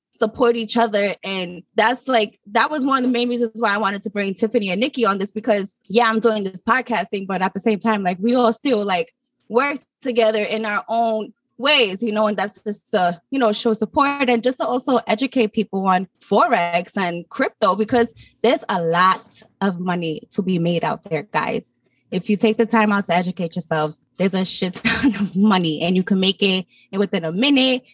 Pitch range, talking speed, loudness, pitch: 190-235 Hz, 215 wpm, -20 LUFS, 220 Hz